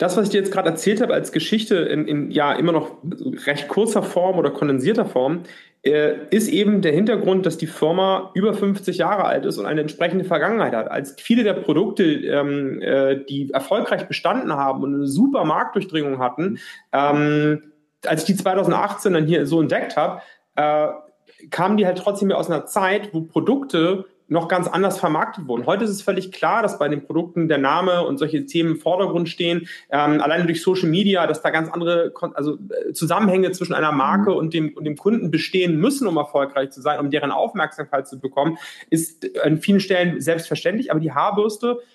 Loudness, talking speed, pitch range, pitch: -20 LUFS, 195 wpm, 150-195 Hz, 170 Hz